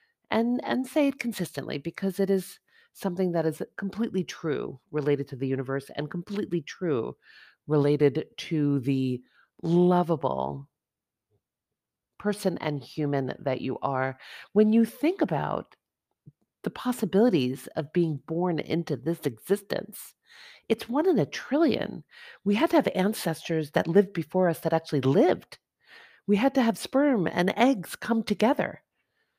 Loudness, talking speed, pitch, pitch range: -27 LUFS, 140 wpm, 175 Hz, 150-225 Hz